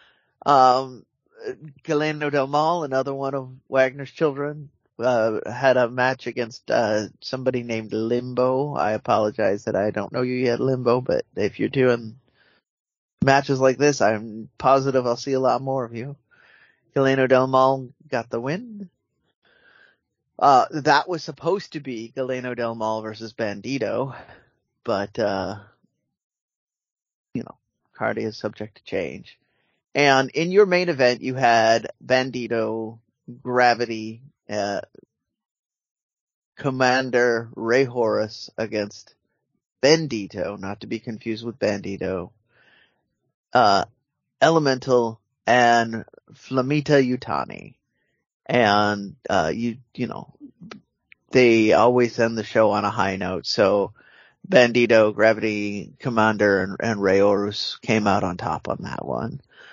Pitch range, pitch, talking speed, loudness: 110-135 Hz, 120 Hz, 125 wpm, -22 LUFS